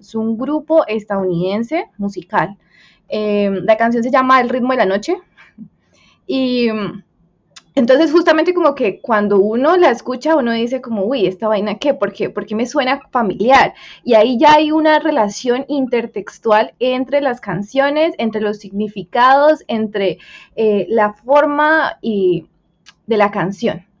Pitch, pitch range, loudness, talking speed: 230 Hz, 205-275 Hz, -15 LUFS, 150 wpm